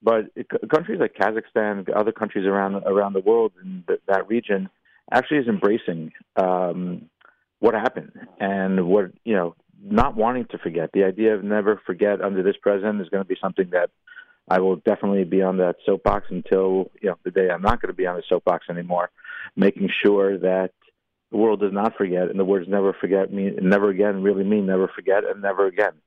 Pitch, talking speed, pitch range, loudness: 100 Hz, 200 wpm, 95-105 Hz, -22 LUFS